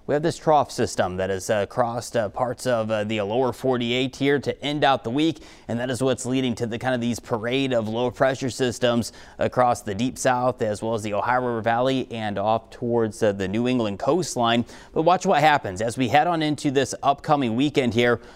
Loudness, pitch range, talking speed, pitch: -23 LUFS, 115-130 Hz, 225 wpm, 120 Hz